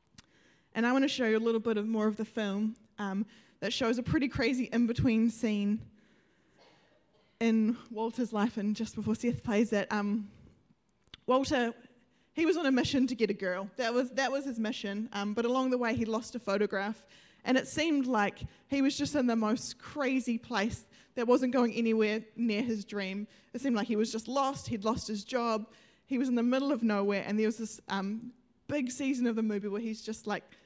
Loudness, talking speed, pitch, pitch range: -32 LUFS, 210 wpm, 230 Hz, 215-250 Hz